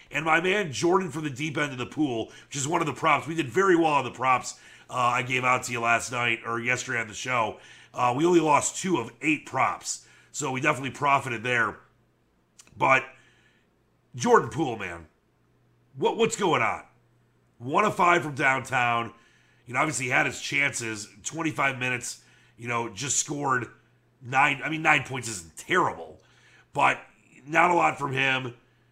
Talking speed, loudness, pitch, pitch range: 185 wpm, -25 LUFS, 130 Hz, 120-155 Hz